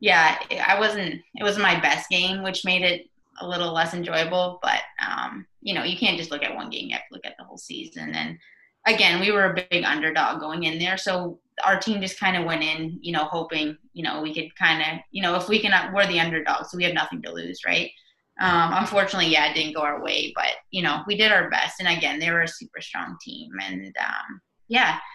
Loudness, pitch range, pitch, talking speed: -23 LUFS, 160-190 Hz, 175 Hz, 245 wpm